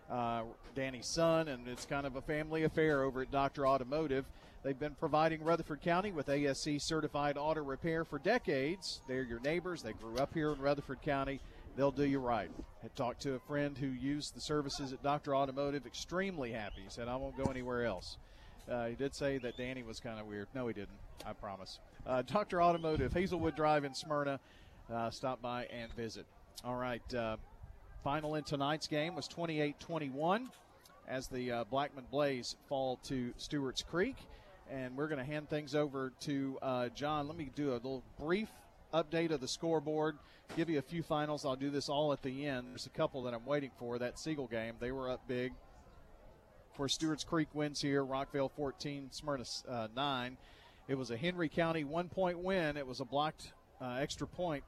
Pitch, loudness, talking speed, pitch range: 140 Hz, -38 LUFS, 195 wpm, 125-150 Hz